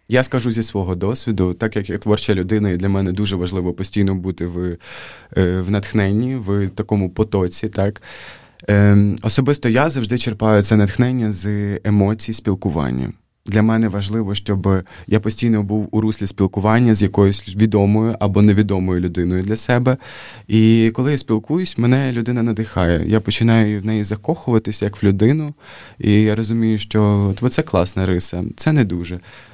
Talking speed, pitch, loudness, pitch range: 155 wpm, 105 Hz, -17 LUFS, 100-115 Hz